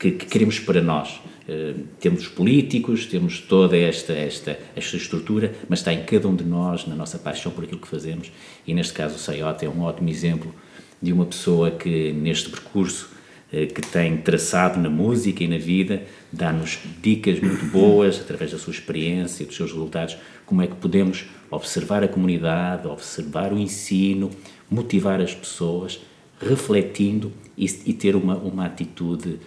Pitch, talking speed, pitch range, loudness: 90 Hz, 170 wpm, 85-95 Hz, -23 LUFS